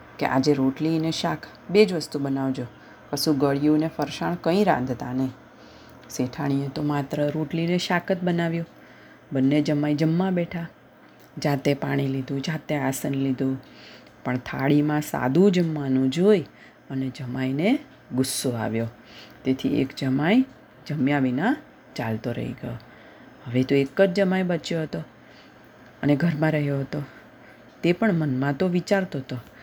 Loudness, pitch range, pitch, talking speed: -24 LUFS, 130-165 Hz, 145 Hz, 135 wpm